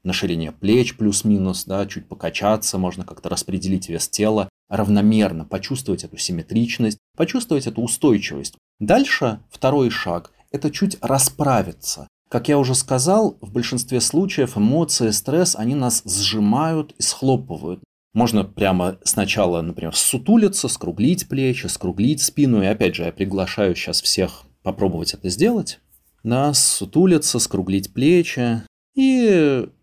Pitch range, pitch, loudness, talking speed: 100-140 Hz, 115 Hz, -19 LUFS, 130 wpm